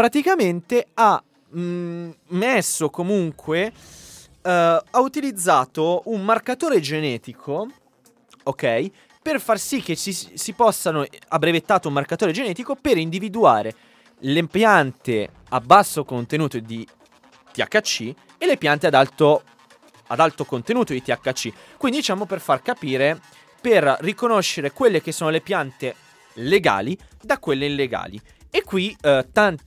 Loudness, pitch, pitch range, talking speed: -21 LUFS, 170 Hz, 145-215 Hz, 125 wpm